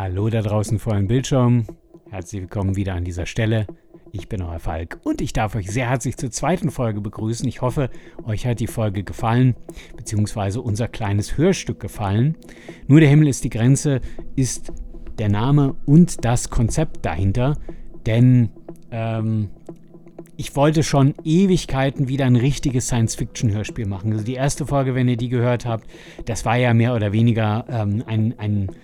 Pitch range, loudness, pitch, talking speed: 110-140 Hz, -20 LUFS, 120 Hz, 165 wpm